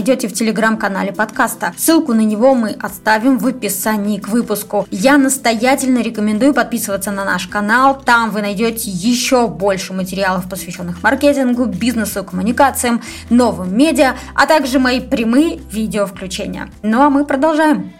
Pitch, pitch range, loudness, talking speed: 230 Hz, 205-260 Hz, -15 LUFS, 135 wpm